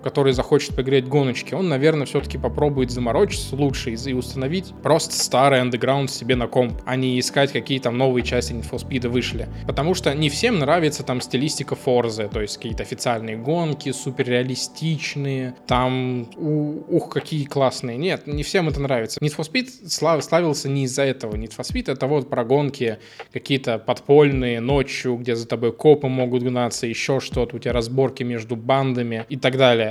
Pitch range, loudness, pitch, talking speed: 125-145 Hz, -21 LUFS, 130 Hz, 175 wpm